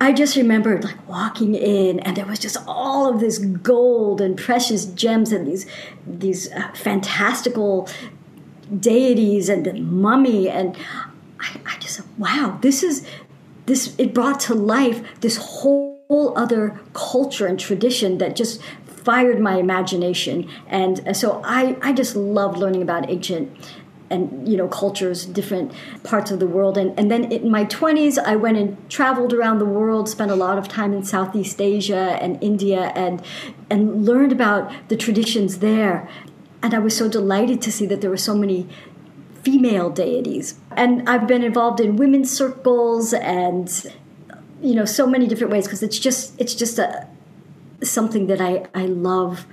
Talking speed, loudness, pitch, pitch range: 165 wpm, -19 LUFS, 210 Hz, 190-245 Hz